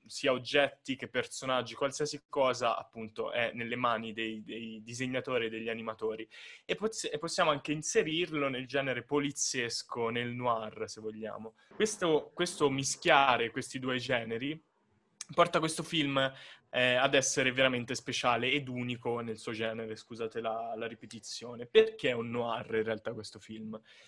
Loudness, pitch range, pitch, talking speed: -32 LUFS, 115-140 Hz, 125 Hz, 145 wpm